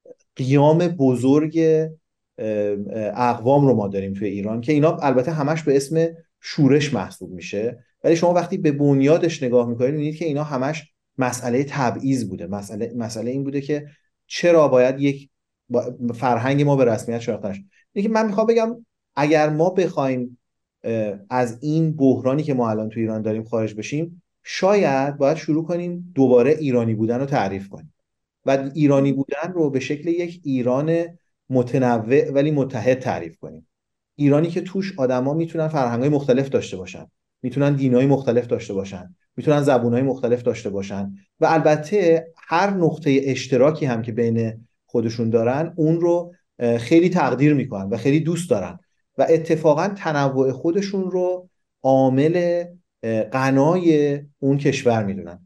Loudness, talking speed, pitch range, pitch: -20 LUFS, 145 wpm, 120-160 Hz, 140 Hz